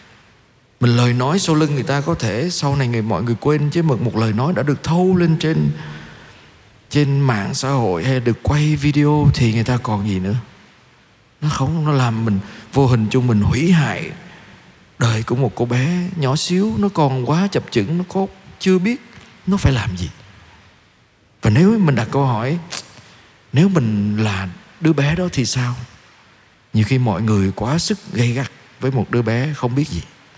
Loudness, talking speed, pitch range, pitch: -18 LUFS, 195 wpm, 115-155 Hz, 130 Hz